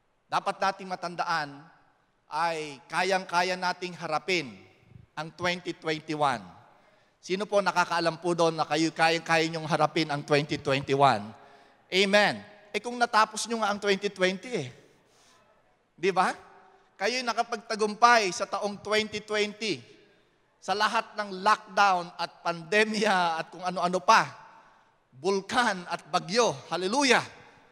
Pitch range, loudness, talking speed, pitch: 160-205 Hz, -27 LUFS, 115 wpm, 180 Hz